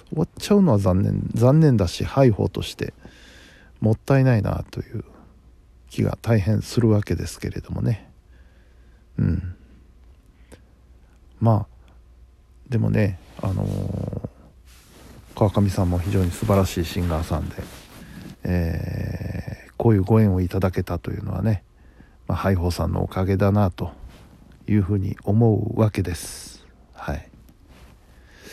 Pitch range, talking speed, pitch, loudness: 80-105 Hz, 240 characters per minute, 95 Hz, -22 LUFS